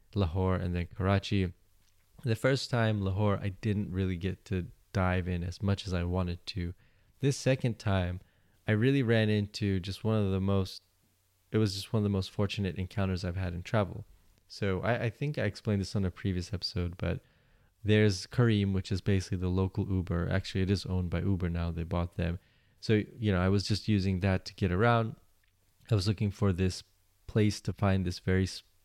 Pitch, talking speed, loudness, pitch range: 95 Hz, 200 wpm, -31 LUFS, 95-105 Hz